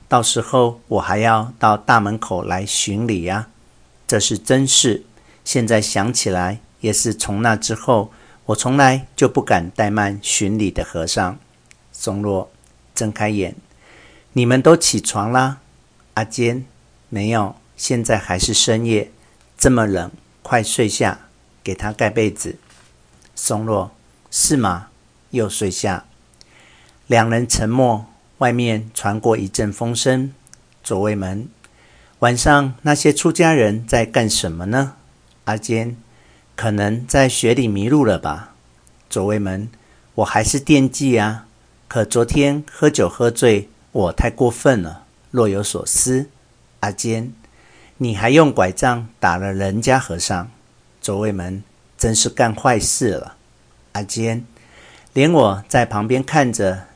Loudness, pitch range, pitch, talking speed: -18 LUFS, 100-120 Hz, 110 Hz, 190 characters per minute